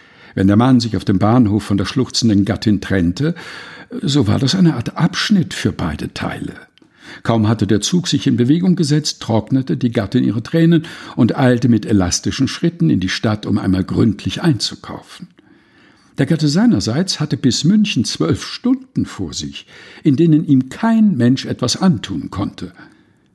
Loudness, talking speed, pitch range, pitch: -16 LUFS, 165 wpm, 105-165 Hz, 130 Hz